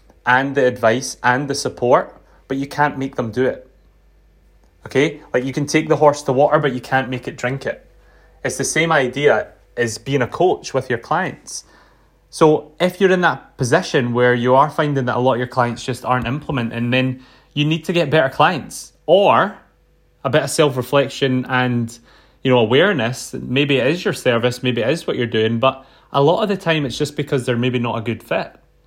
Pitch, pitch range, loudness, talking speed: 130 Hz, 125-145 Hz, -18 LUFS, 210 wpm